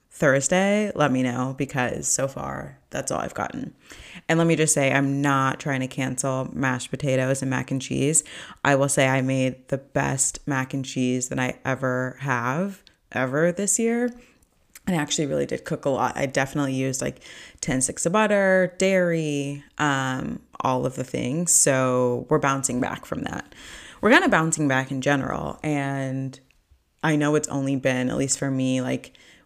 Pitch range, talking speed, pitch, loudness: 130-150 Hz, 185 wpm, 135 Hz, -23 LUFS